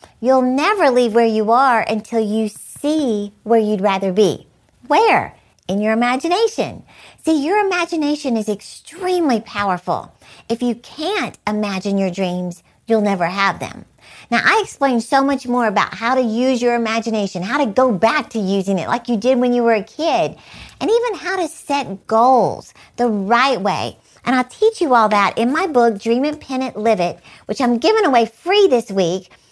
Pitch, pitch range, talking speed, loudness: 235 Hz, 210-280 Hz, 185 wpm, -17 LUFS